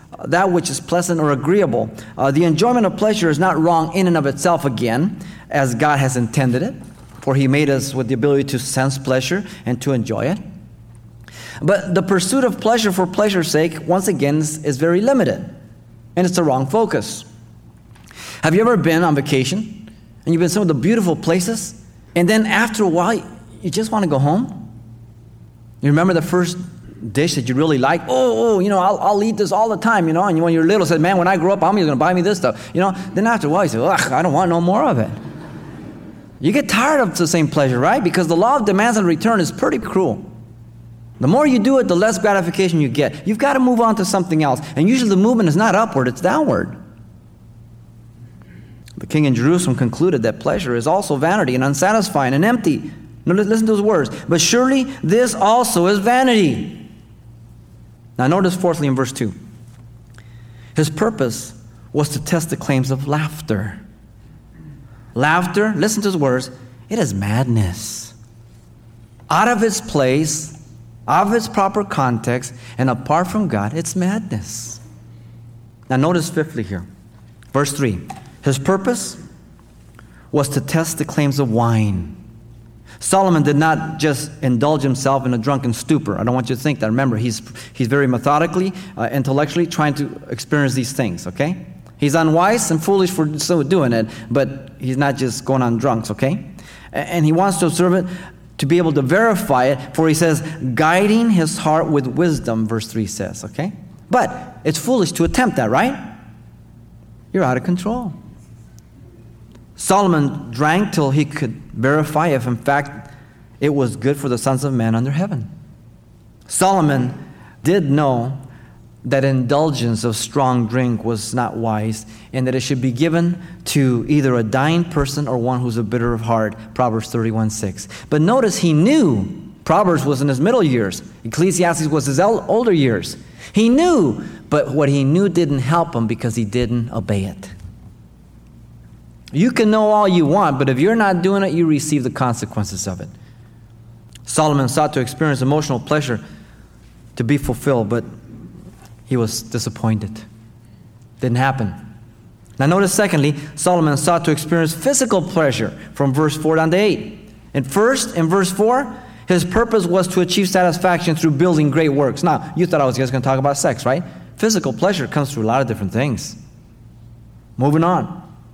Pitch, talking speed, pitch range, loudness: 145 Hz, 180 wpm, 120-180 Hz, -17 LUFS